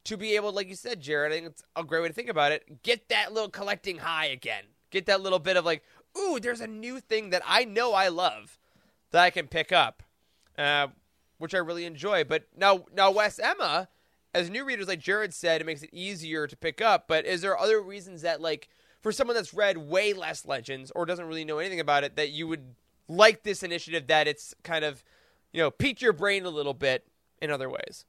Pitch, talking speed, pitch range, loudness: 180 Hz, 235 wpm, 160-205 Hz, -27 LUFS